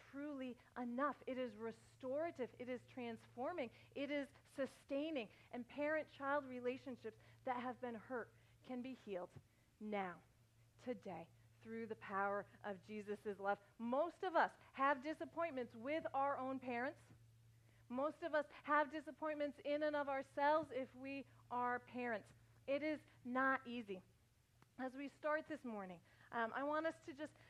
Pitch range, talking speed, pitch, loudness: 210-285 Hz, 140 wpm, 255 Hz, -45 LUFS